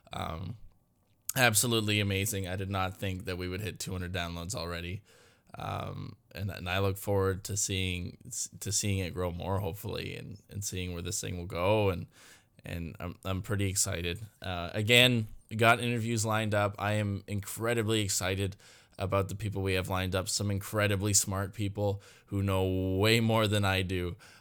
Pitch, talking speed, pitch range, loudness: 100 Hz, 170 wpm, 95-105 Hz, -31 LUFS